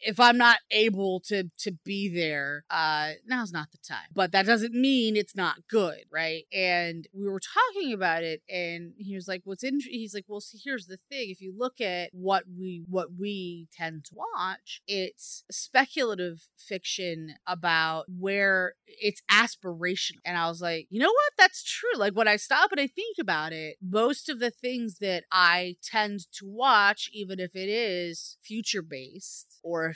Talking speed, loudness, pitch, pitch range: 185 wpm, -27 LUFS, 195 Hz, 175-230 Hz